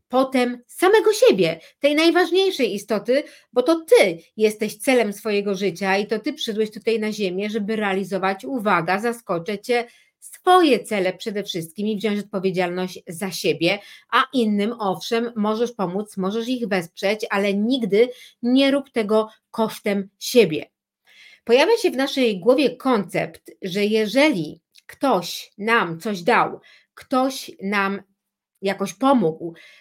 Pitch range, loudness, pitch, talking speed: 195-255 Hz, -21 LUFS, 220 Hz, 130 wpm